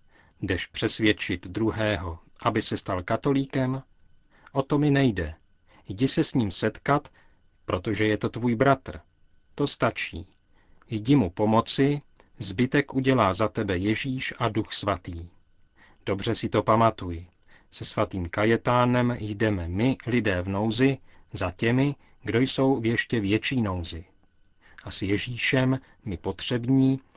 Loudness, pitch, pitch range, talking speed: -25 LUFS, 110 Hz, 95-130 Hz, 130 wpm